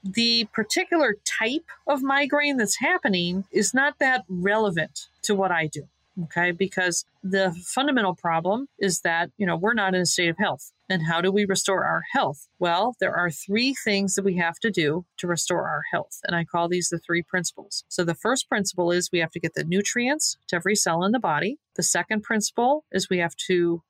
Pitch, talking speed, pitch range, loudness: 190 Hz, 210 wpm, 175-225 Hz, -24 LUFS